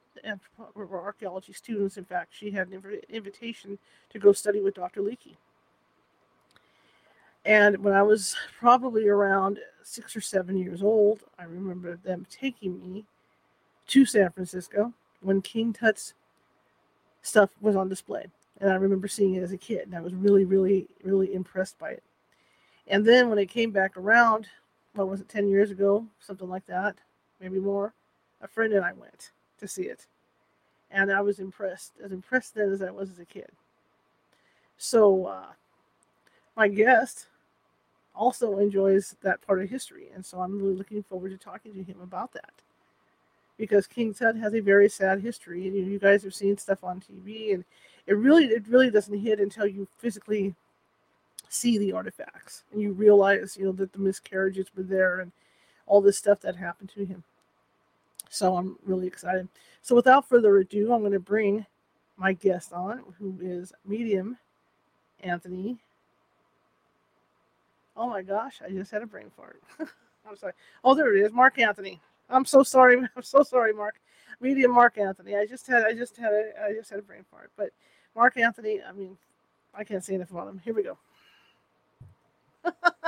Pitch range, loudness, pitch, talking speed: 190-220 Hz, -25 LUFS, 200 Hz, 175 wpm